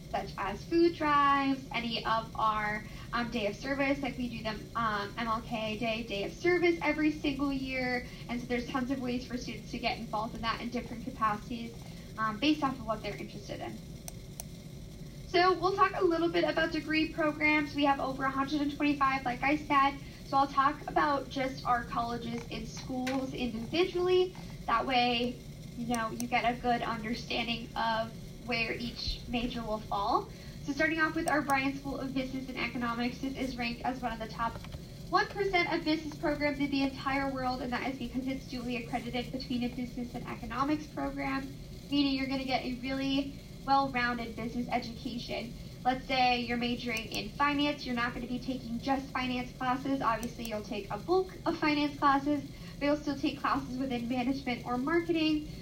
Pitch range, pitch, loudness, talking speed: 235-285 Hz, 255 Hz, -32 LUFS, 185 wpm